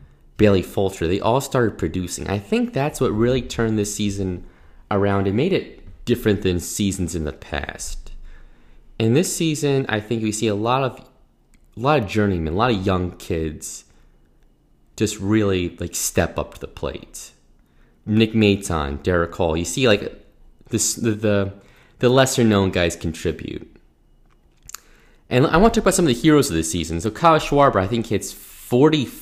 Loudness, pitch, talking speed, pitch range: -20 LUFS, 100 Hz, 170 wpm, 85-120 Hz